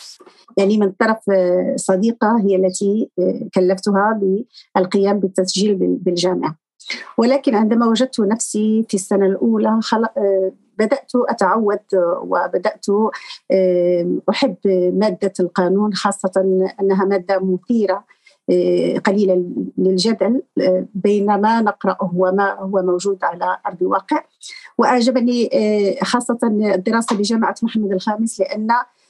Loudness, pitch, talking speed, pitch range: -17 LUFS, 205 Hz, 95 wpm, 190-225 Hz